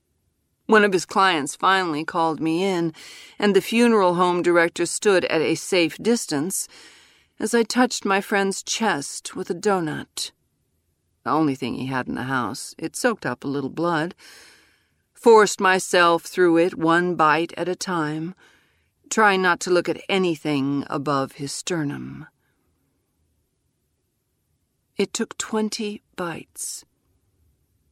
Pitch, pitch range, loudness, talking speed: 170 Hz, 140-195 Hz, -21 LUFS, 135 wpm